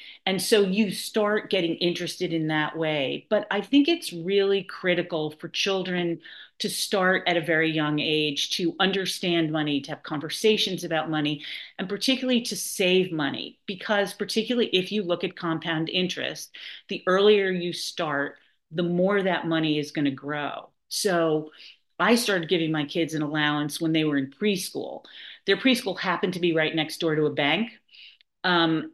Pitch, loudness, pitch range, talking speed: 175 Hz, -25 LUFS, 155-200 Hz, 170 wpm